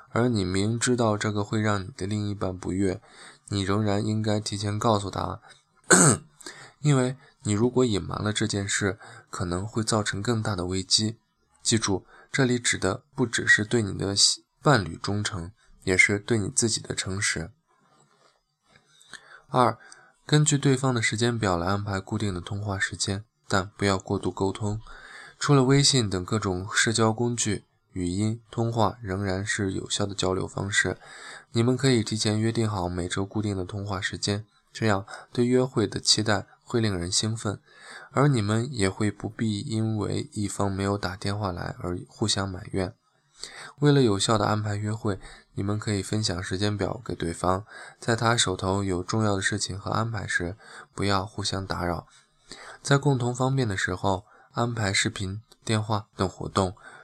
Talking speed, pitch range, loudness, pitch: 245 characters per minute, 95-115 Hz, -26 LUFS, 105 Hz